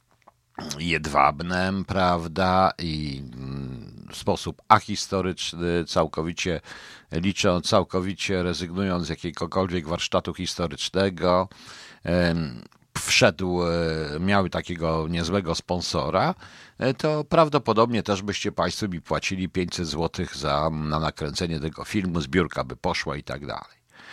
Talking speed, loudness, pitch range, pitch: 95 wpm, -25 LUFS, 80-95 Hz, 90 Hz